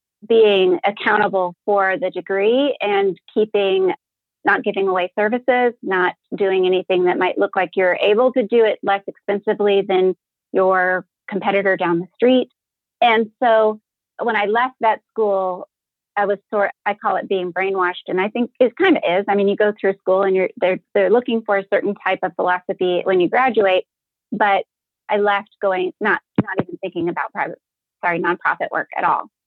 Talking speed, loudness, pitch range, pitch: 180 wpm, -18 LUFS, 185-215 Hz, 200 Hz